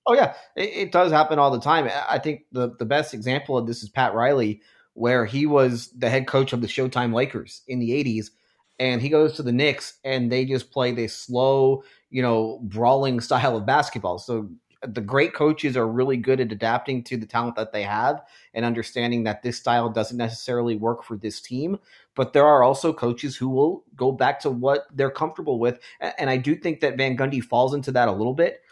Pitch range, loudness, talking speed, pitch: 115-135 Hz, -23 LUFS, 215 wpm, 125 Hz